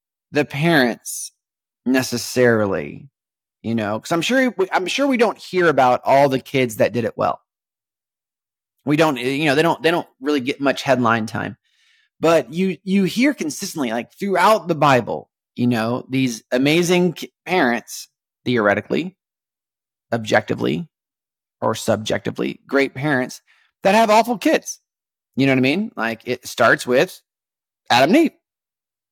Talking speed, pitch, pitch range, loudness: 145 wpm, 140 Hz, 125-180 Hz, -19 LUFS